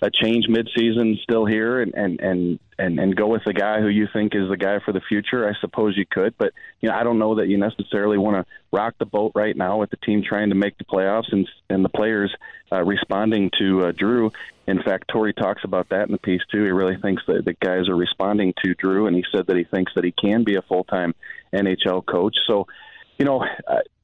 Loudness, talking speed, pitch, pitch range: -21 LUFS, 245 wpm, 105 Hz, 95-110 Hz